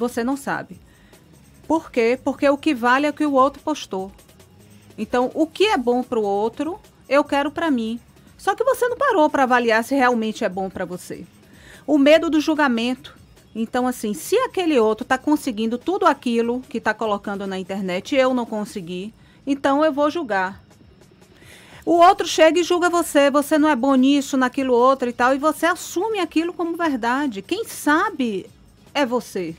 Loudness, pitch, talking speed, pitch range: -20 LUFS, 270 Hz, 185 wpm, 230-310 Hz